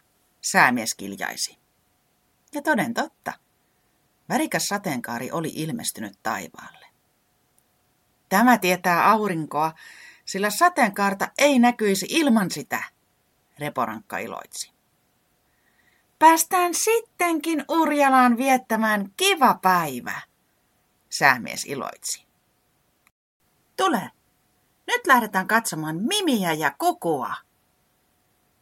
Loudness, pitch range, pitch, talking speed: -22 LUFS, 190-315 Hz, 240 Hz, 75 wpm